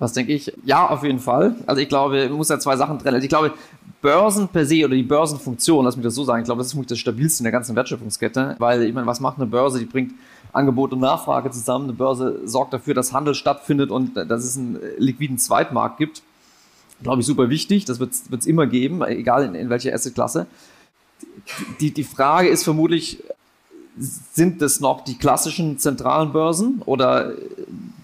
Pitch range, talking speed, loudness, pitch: 130-155 Hz, 210 wpm, -20 LUFS, 140 Hz